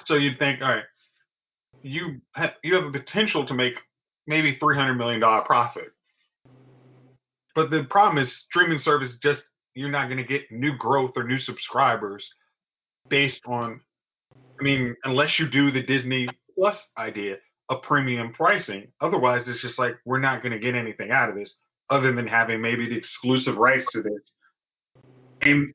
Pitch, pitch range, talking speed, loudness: 130 Hz, 125-145 Hz, 170 wpm, -23 LUFS